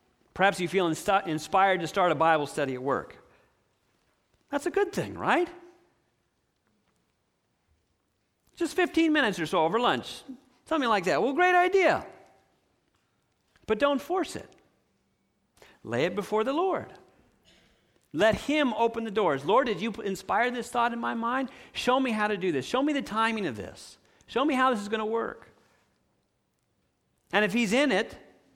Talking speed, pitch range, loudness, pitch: 160 wpm, 200-290 Hz, -27 LUFS, 230 Hz